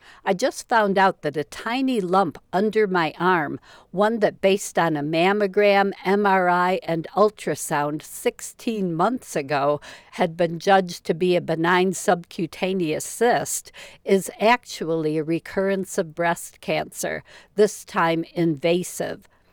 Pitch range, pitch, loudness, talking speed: 165-205 Hz, 185 Hz, -22 LUFS, 130 wpm